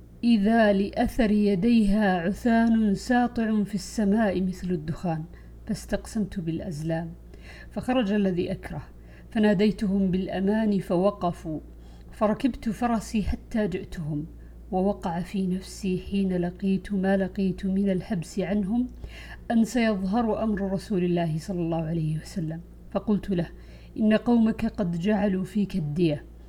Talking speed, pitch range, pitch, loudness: 110 wpm, 180-215 Hz, 195 Hz, -26 LUFS